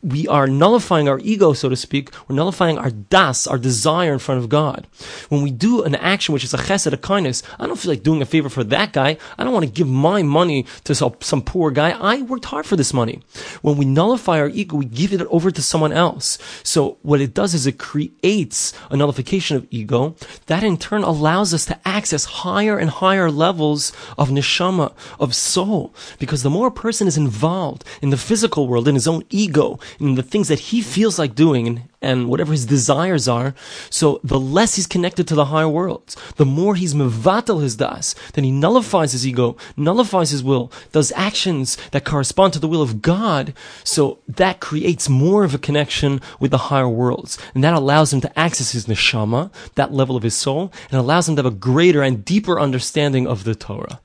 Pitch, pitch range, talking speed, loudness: 150 Hz, 135-180 Hz, 210 wpm, -18 LUFS